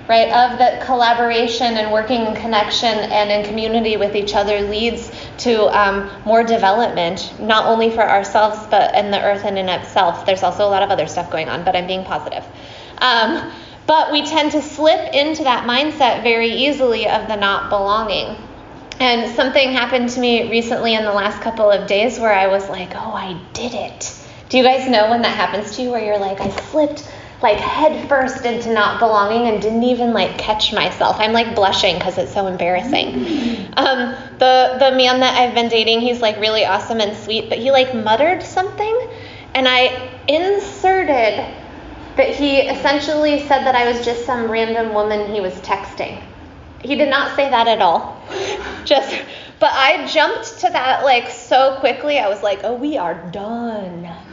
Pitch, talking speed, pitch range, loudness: 230 Hz, 185 wpm, 205-265 Hz, -16 LUFS